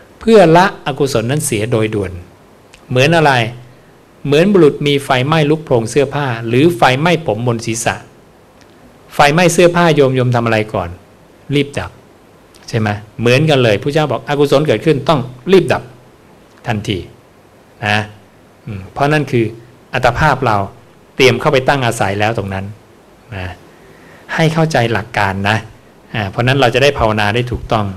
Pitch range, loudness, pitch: 105-145 Hz, -13 LUFS, 120 Hz